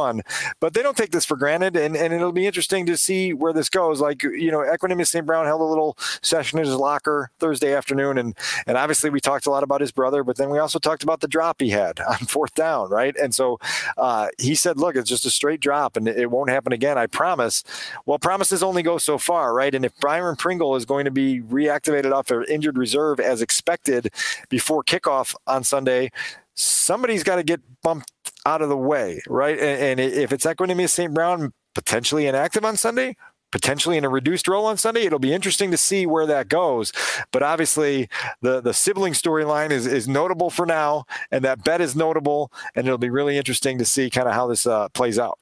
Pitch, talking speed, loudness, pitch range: 150 Hz, 215 wpm, -21 LUFS, 135-165 Hz